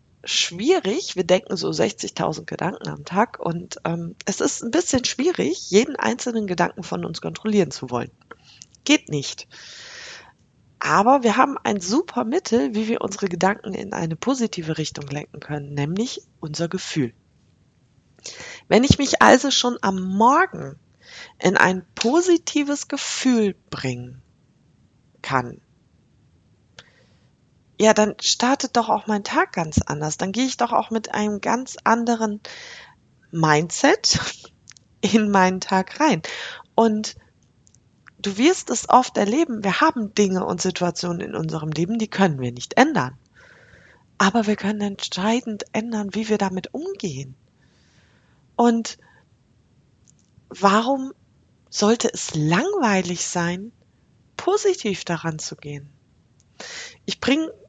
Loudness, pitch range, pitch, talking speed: -21 LUFS, 170-245 Hz, 205 Hz, 125 wpm